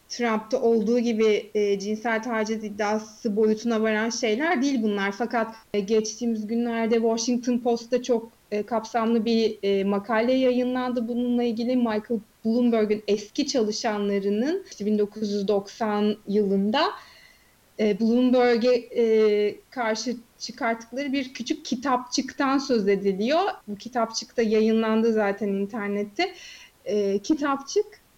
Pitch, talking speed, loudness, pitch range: 230 Hz, 110 wpm, -25 LUFS, 215-245 Hz